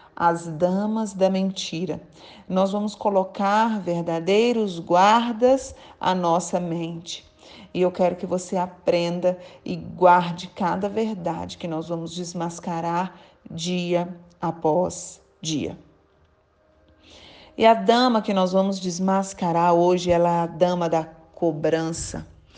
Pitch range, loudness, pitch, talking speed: 170-190 Hz, -23 LUFS, 180 Hz, 115 wpm